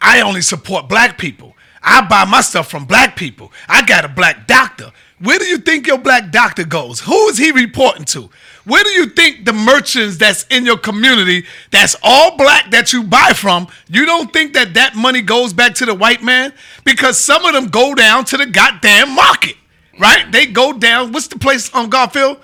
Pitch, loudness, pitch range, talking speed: 255 Hz, -9 LUFS, 230-275 Hz, 210 wpm